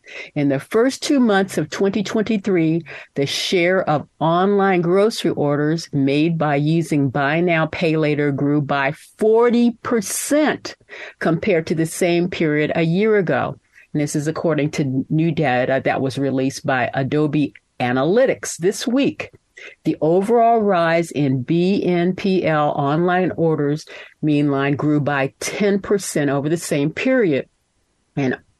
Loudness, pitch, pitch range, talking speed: -19 LUFS, 165 Hz, 145-195 Hz, 130 wpm